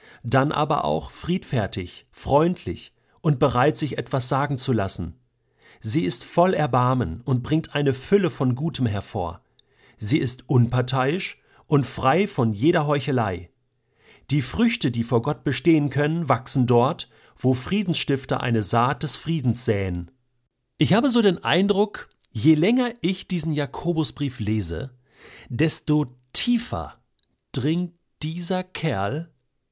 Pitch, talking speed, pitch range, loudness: 140 Hz, 125 wpm, 125-160 Hz, -23 LUFS